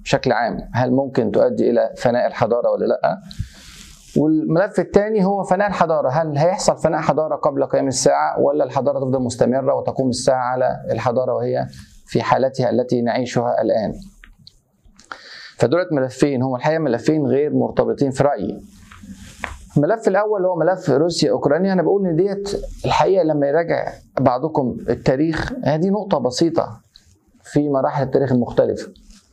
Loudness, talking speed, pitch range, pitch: -19 LUFS, 135 wpm, 130-185 Hz, 150 Hz